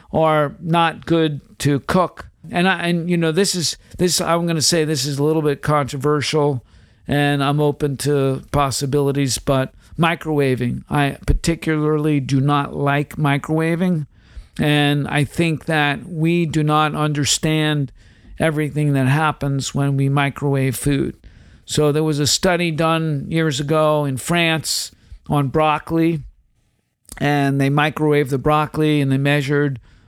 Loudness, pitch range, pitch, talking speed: -18 LUFS, 140-160 Hz, 150 Hz, 140 wpm